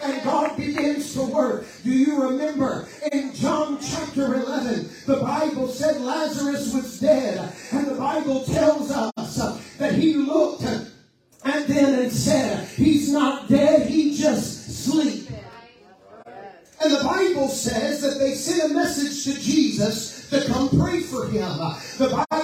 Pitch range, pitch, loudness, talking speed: 265-300 Hz, 280 Hz, -22 LUFS, 145 wpm